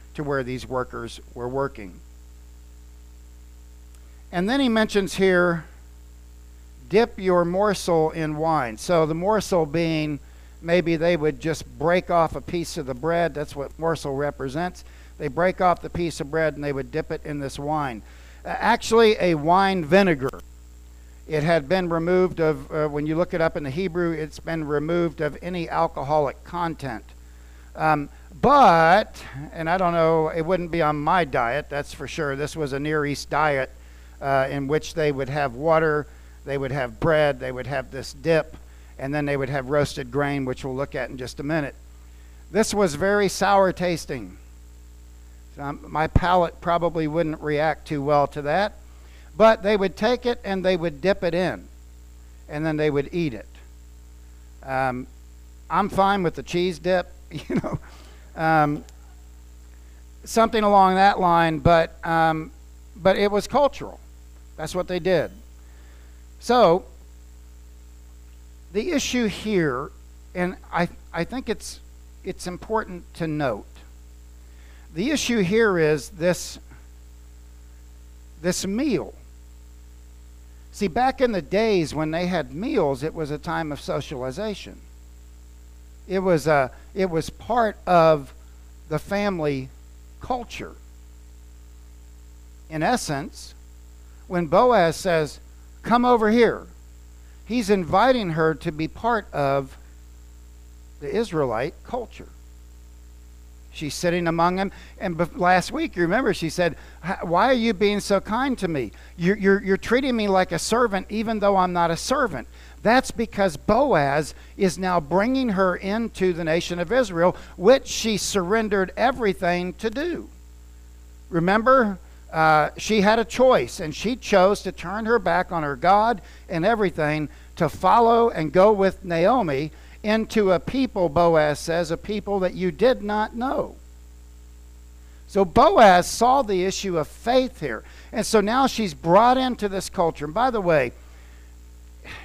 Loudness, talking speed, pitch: -22 LUFS, 150 wpm, 155 Hz